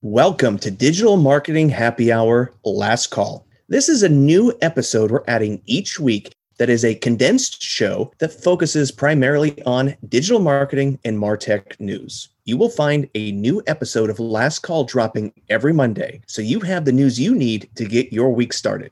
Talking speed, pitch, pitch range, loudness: 175 wpm, 130 Hz, 115-145 Hz, -18 LUFS